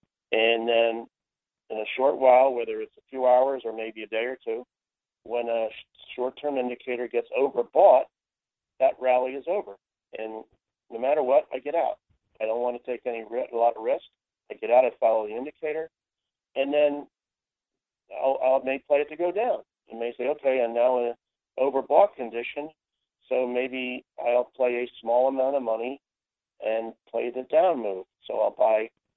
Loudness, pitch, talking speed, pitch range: -26 LUFS, 125 Hz, 190 wpm, 115-140 Hz